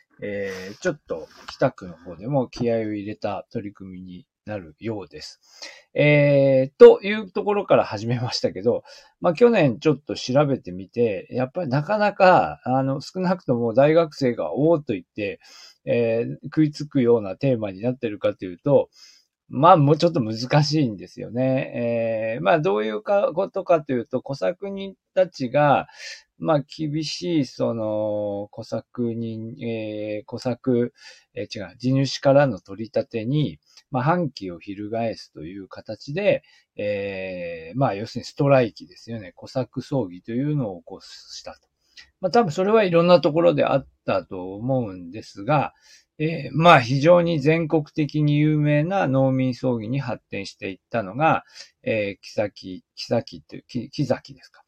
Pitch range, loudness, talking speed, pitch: 110-155 Hz, -22 LUFS, 305 characters per minute, 130 Hz